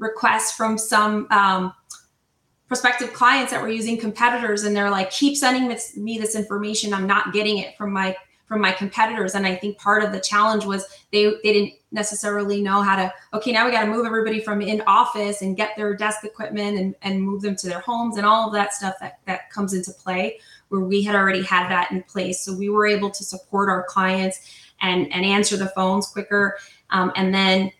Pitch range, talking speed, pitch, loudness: 190-215 Hz, 215 wpm, 205 Hz, -21 LUFS